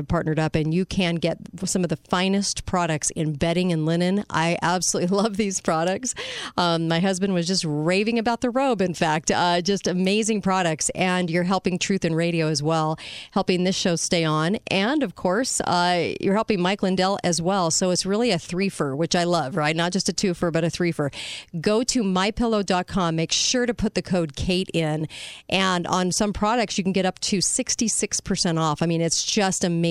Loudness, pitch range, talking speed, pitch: -23 LUFS, 165-200 Hz, 210 wpm, 180 Hz